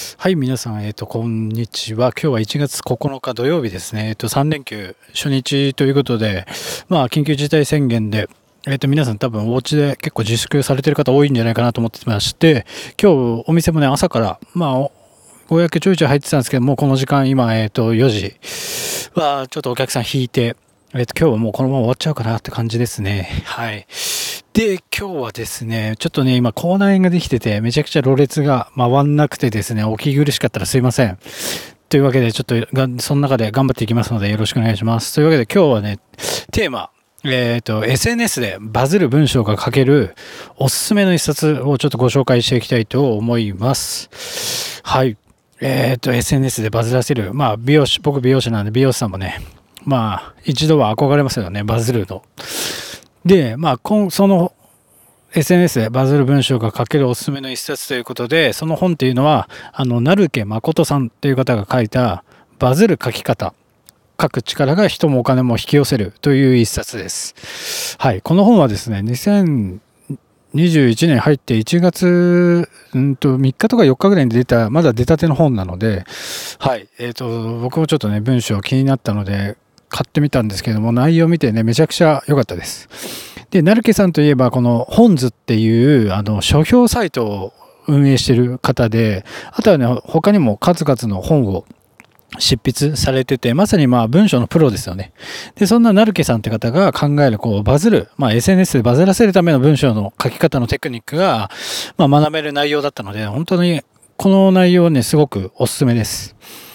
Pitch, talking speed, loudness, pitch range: 130 Hz, 375 characters per minute, -15 LUFS, 115-150 Hz